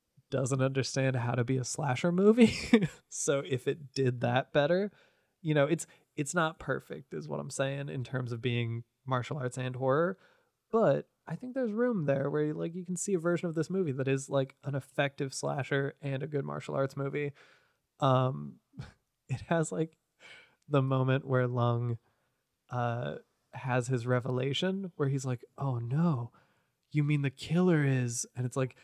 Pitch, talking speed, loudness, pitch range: 135 Hz, 180 wpm, -32 LUFS, 130-155 Hz